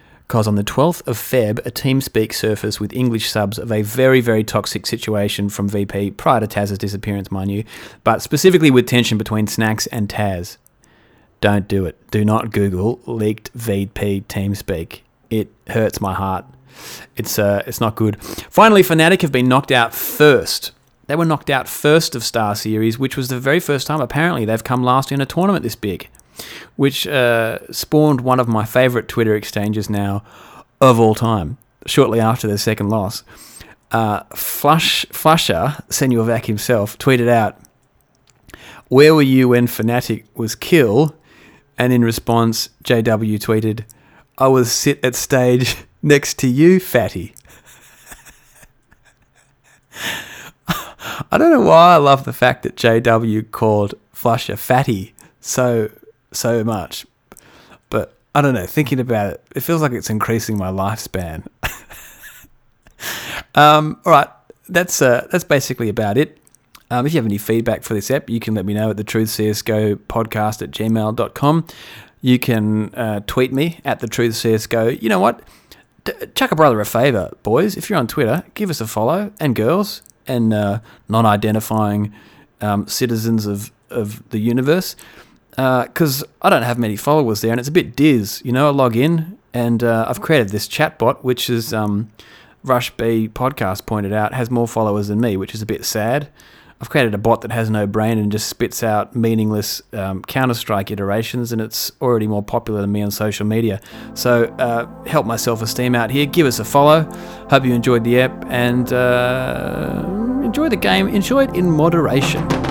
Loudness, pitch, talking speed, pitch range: -17 LUFS, 115 Hz, 175 wpm, 110-135 Hz